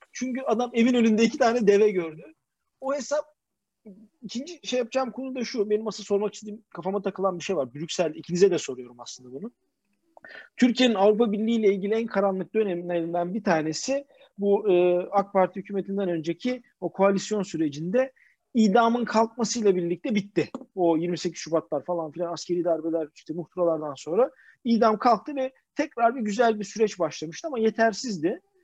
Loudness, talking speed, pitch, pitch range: -25 LUFS, 155 wpm, 205 Hz, 175-235 Hz